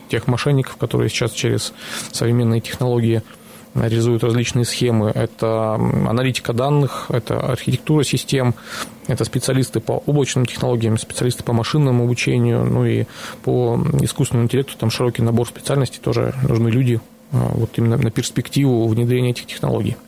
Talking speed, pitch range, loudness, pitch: 130 wpm, 115-130 Hz, -19 LUFS, 120 Hz